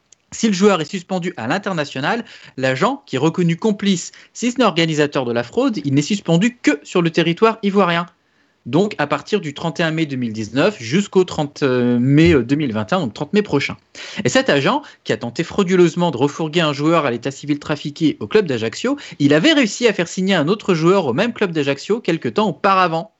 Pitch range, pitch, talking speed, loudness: 145-200 Hz, 170 Hz, 195 wpm, -18 LUFS